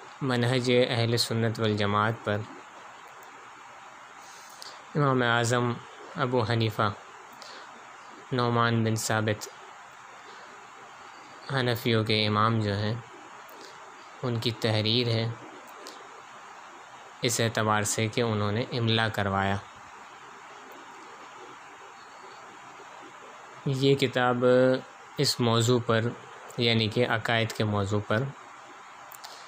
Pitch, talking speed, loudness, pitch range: 115 Hz, 80 wpm, -27 LUFS, 110-125 Hz